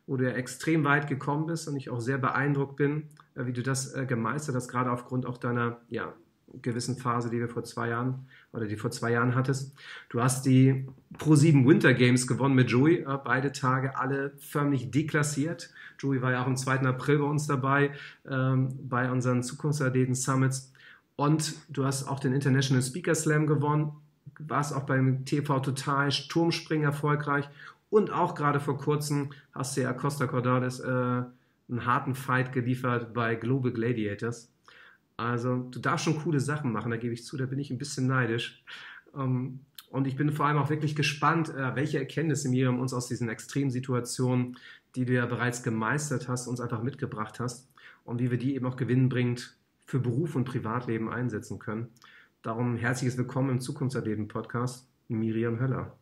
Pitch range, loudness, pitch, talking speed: 125-145 Hz, -29 LUFS, 130 Hz, 180 wpm